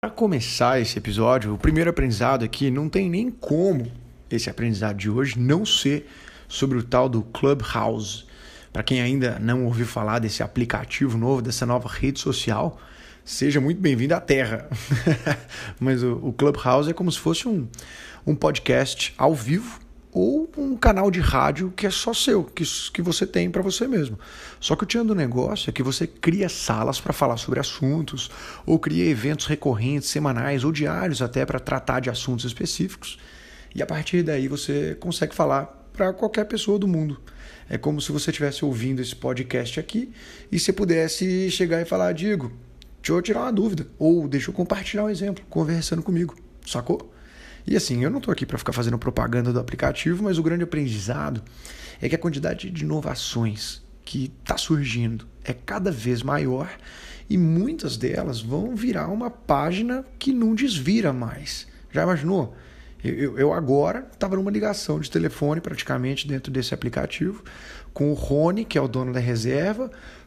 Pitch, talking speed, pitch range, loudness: 145 Hz, 170 wpm, 125-185 Hz, -24 LUFS